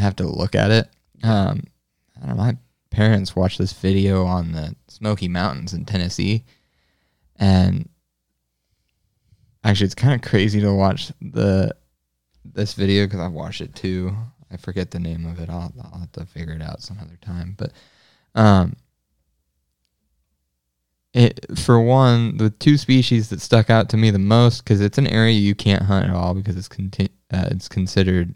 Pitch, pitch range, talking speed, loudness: 95 Hz, 85-110 Hz, 175 wpm, -19 LUFS